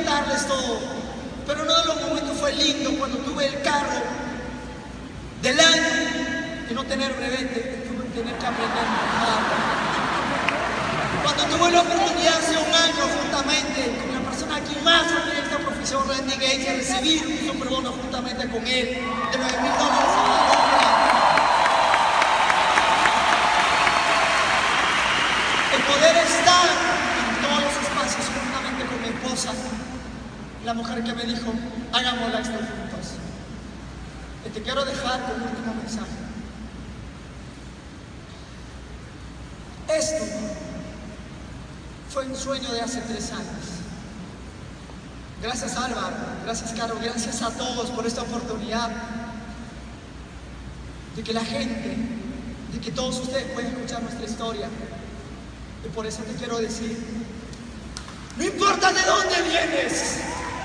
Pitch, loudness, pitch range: 250 Hz, -22 LUFS, 230-285 Hz